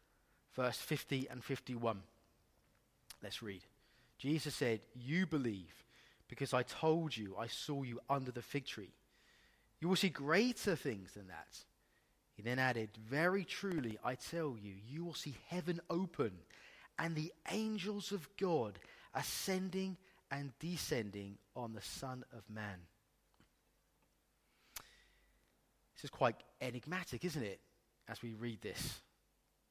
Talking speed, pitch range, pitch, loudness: 130 wpm, 115-170 Hz, 135 Hz, -41 LUFS